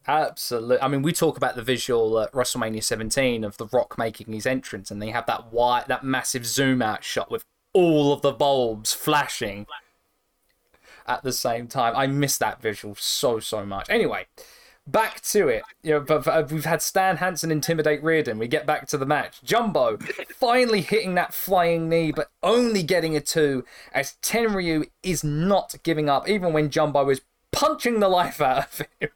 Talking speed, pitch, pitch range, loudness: 185 wpm, 150 Hz, 125-170 Hz, -23 LUFS